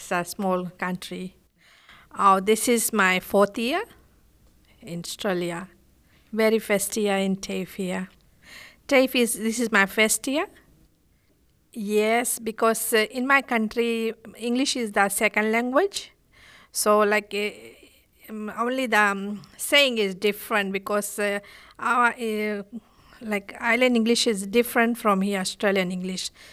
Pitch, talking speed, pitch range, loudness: 215 Hz, 130 wpm, 195-235 Hz, -23 LUFS